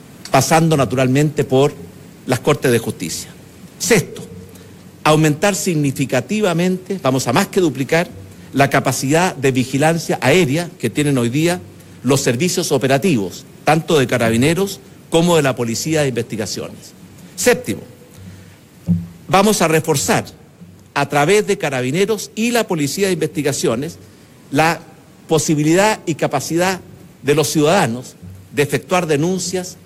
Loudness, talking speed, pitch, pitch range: -17 LUFS, 120 wpm, 150 Hz, 130-175 Hz